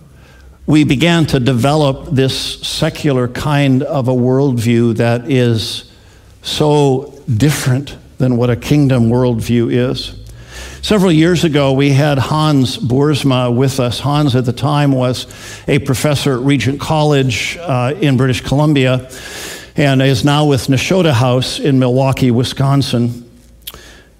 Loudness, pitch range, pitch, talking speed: -13 LUFS, 120-145 Hz, 130 Hz, 130 wpm